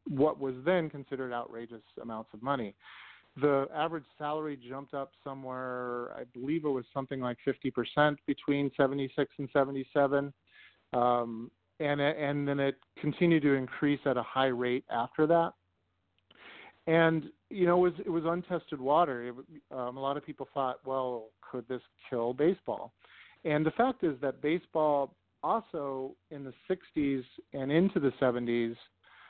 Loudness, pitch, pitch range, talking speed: -32 LUFS, 140 Hz, 125-150 Hz, 150 wpm